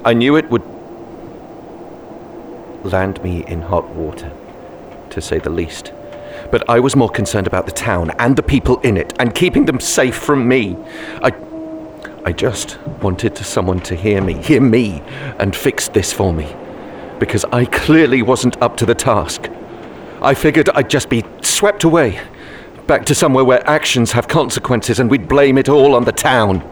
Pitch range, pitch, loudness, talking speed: 95-140 Hz, 120 Hz, -14 LUFS, 175 wpm